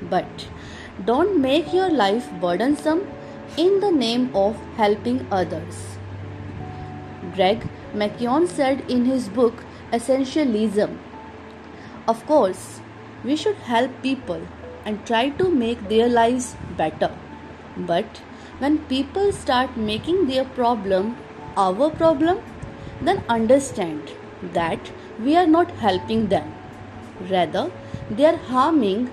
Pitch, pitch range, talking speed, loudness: 250 Hz, 210-300 Hz, 110 wpm, -21 LUFS